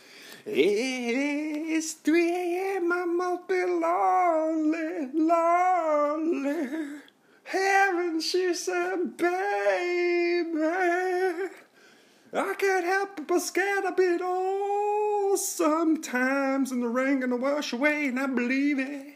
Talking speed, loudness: 110 wpm, -26 LUFS